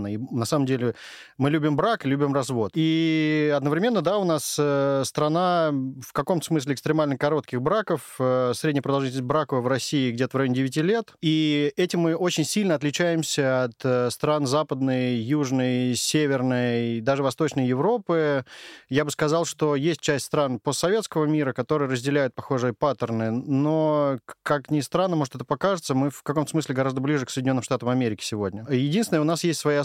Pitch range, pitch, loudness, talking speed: 130-155 Hz, 145 Hz, -24 LUFS, 165 wpm